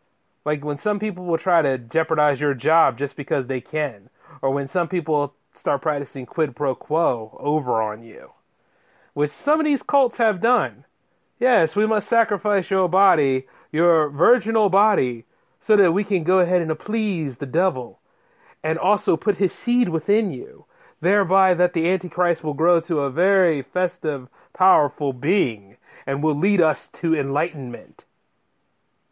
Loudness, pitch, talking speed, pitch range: -21 LUFS, 170 Hz, 160 wpm, 145-200 Hz